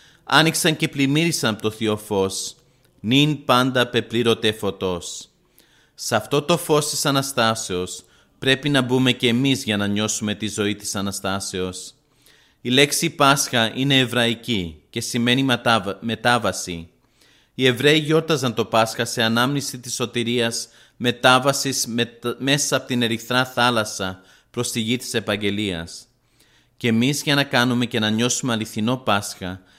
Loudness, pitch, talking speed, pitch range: -20 LUFS, 120 Hz, 135 wpm, 105-130 Hz